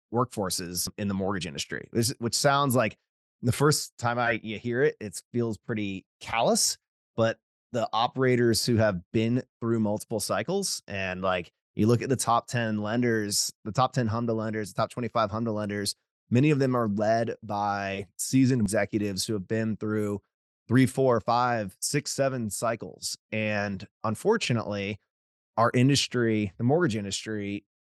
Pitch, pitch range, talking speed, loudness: 110 Hz, 105-120 Hz, 160 wpm, -27 LUFS